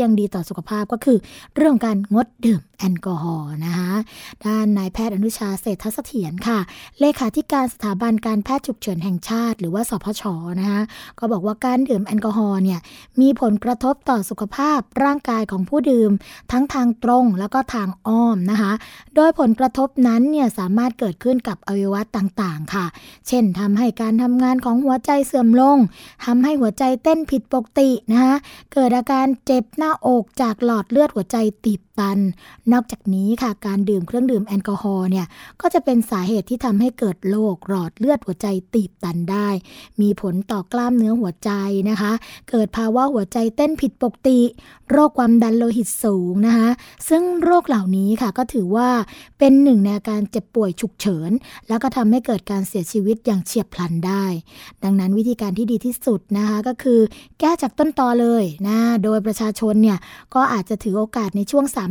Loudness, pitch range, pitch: -19 LUFS, 200-255 Hz, 225 Hz